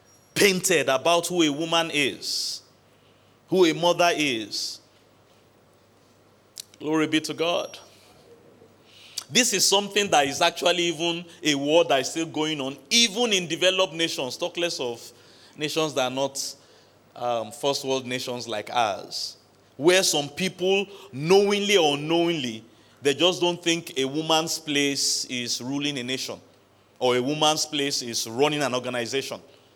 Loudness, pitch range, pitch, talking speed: -23 LUFS, 125-170 Hz, 150 Hz, 140 wpm